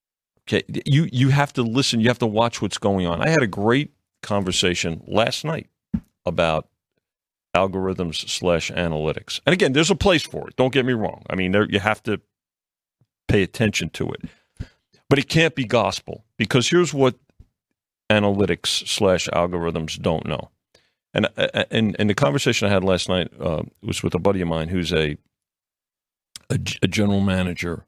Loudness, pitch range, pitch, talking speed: -21 LUFS, 90-120 Hz, 100 Hz, 175 wpm